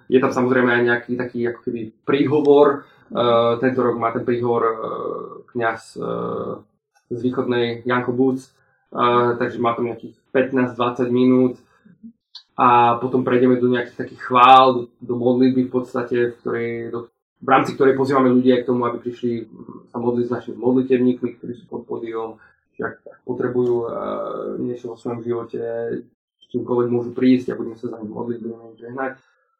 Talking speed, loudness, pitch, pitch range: 160 wpm, -20 LUFS, 120 Hz, 120-130 Hz